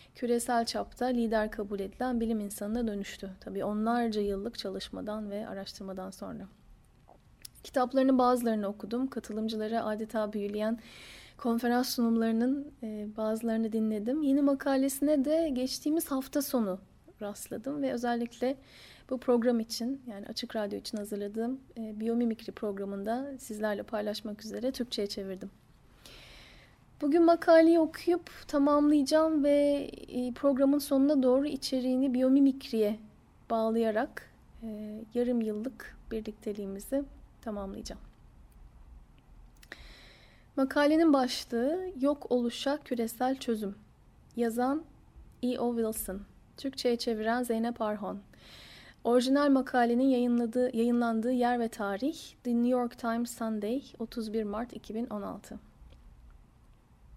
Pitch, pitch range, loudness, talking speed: 235 Hz, 215-265 Hz, -31 LUFS, 95 wpm